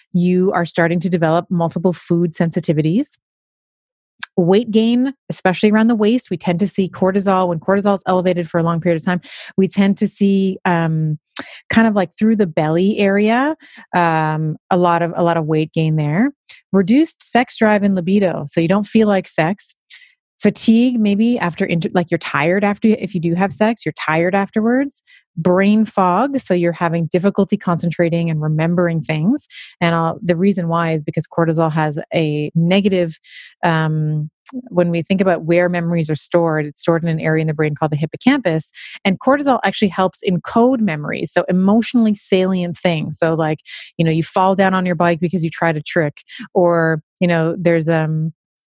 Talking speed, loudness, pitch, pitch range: 180 wpm, -17 LUFS, 180 Hz, 165-205 Hz